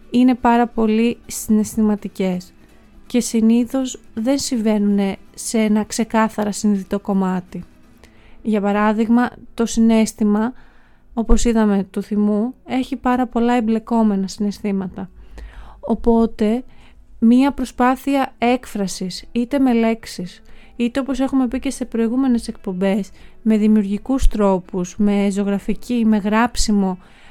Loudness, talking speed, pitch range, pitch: -19 LUFS, 105 wpm, 205-240 Hz, 225 Hz